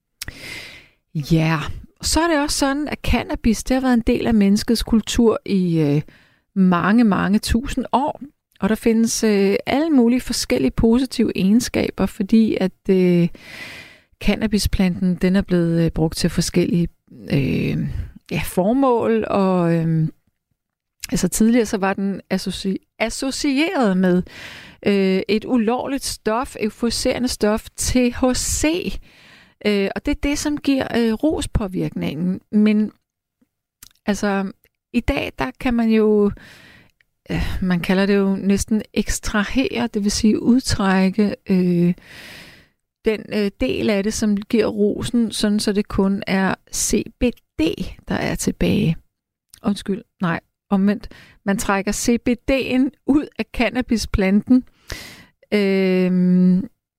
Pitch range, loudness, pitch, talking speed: 190-240 Hz, -19 LUFS, 210 Hz, 125 wpm